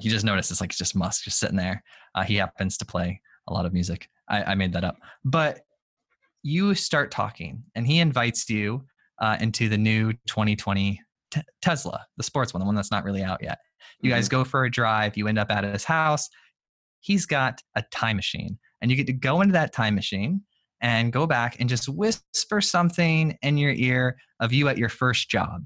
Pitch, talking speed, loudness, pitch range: 120 Hz, 215 wpm, -25 LUFS, 105-145 Hz